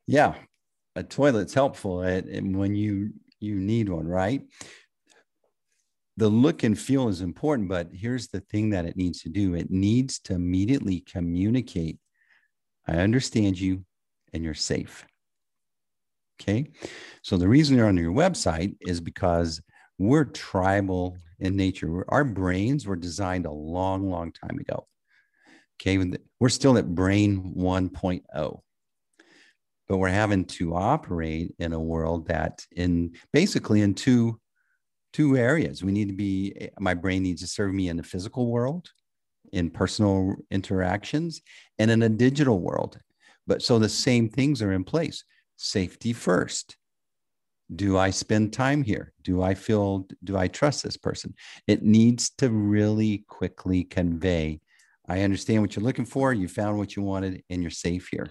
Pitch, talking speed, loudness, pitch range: 95 Hz, 150 wpm, -25 LUFS, 90-115 Hz